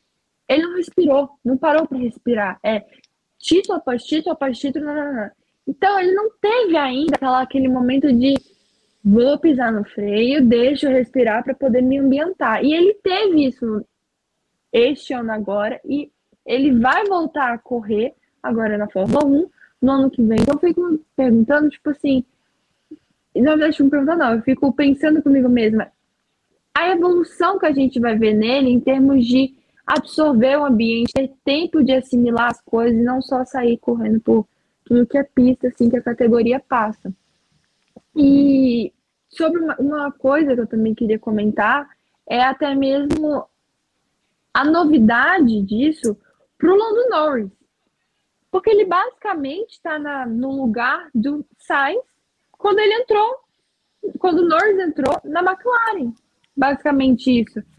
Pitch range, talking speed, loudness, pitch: 240-310 Hz, 155 wpm, -18 LUFS, 270 Hz